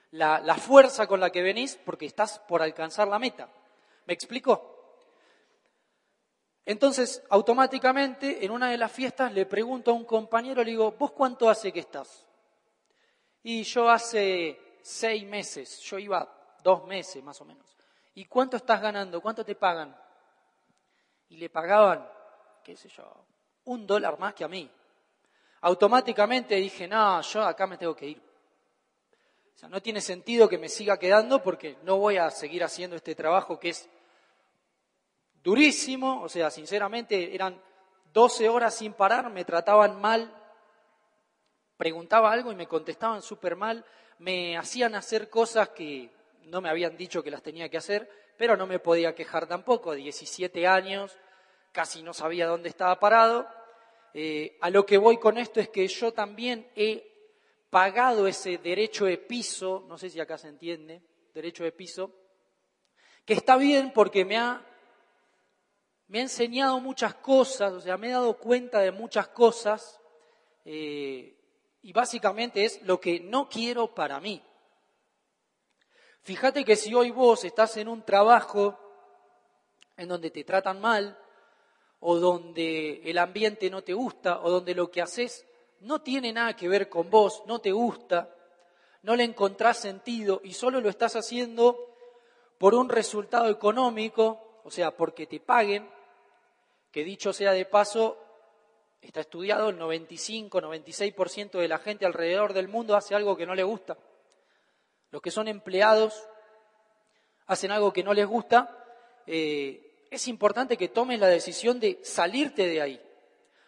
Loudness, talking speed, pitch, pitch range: -26 LUFS, 155 wpm, 205 Hz, 180-235 Hz